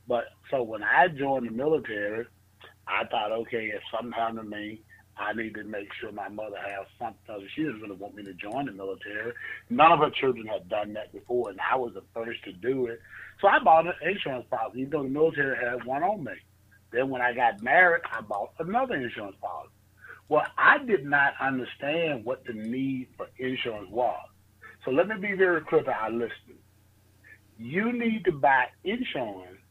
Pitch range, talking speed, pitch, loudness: 100-140 Hz, 200 wpm, 115 Hz, -27 LUFS